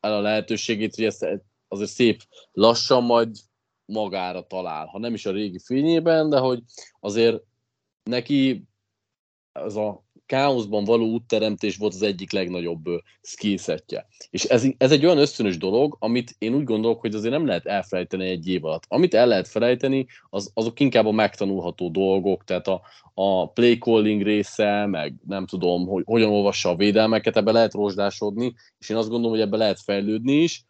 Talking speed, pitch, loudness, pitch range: 170 wpm, 110 Hz, -22 LUFS, 100-120 Hz